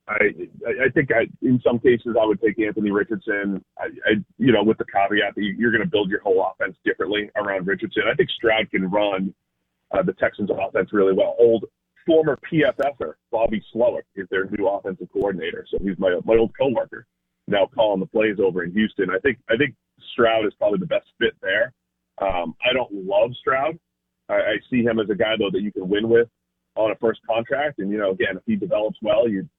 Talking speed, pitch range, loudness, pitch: 215 wpm, 95-115 Hz, -22 LUFS, 105 Hz